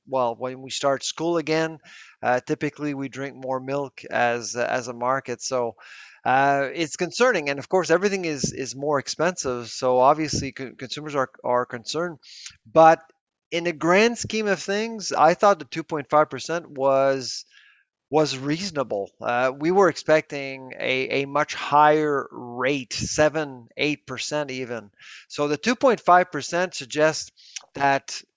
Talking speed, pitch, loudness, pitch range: 140 wpm, 145 Hz, -23 LUFS, 130-160 Hz